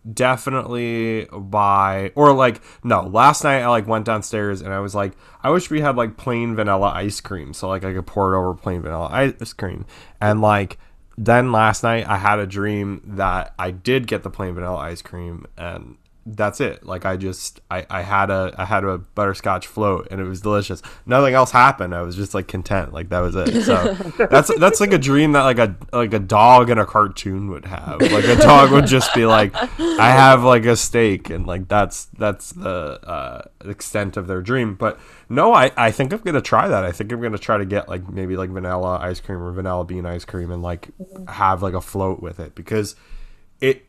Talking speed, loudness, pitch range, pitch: 220 wpm, -17 LUFS, 95-115 Hz, 100 Hz